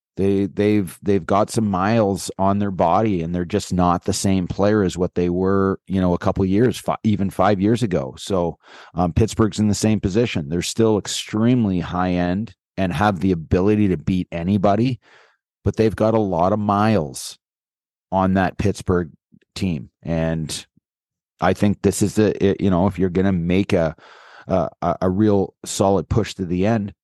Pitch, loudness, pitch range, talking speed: 100 Hz, -20 LUFS, 90-105 Hz, 180 wpm